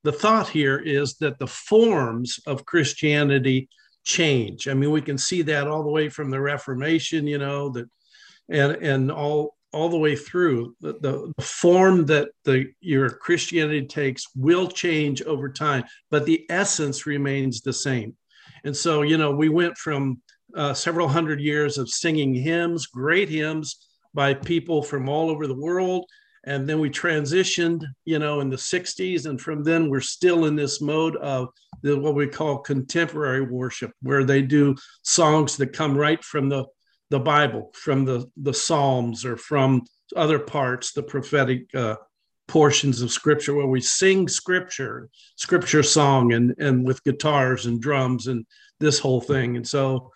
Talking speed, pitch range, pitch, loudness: 165 wpm, 135-155 Hz, 145 Hz, -22 LUFS